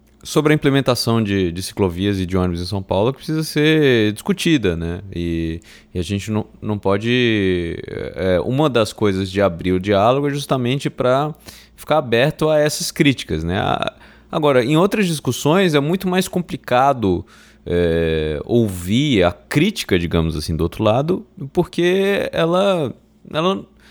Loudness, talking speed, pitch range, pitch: -18 LUFS, 155 wpm, 95-155 Hz, 120 Hz